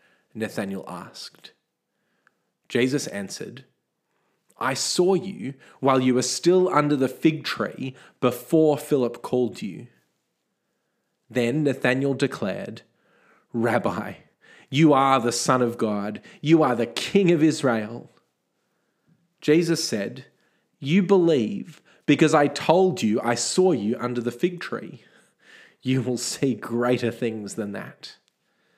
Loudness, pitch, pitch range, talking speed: -23 LUFS, 130 Hz, 120-160 Hz, 120 wpm